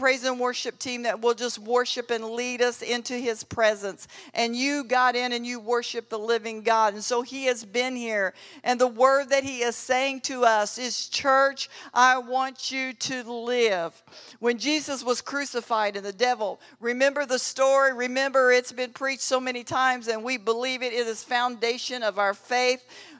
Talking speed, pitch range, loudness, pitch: 190 wpm, 235-260 Hz, -25 LUFS, 245 Hz